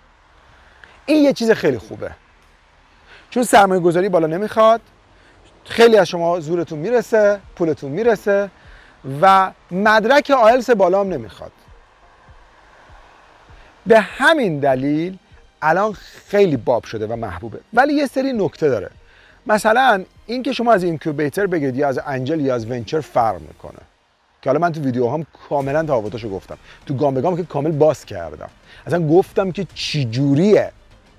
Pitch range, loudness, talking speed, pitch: 140-215 Hz, -17 LUFS, 140 wpm, 175 Hz